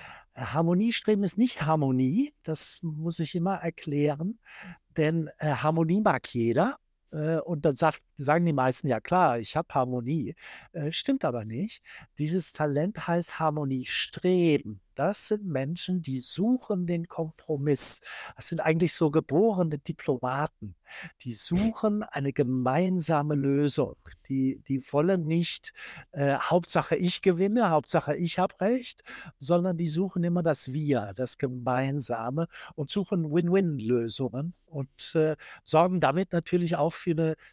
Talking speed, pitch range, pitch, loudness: 135 wpm, 140-180 Hz, 160 Hz, -28 LUFS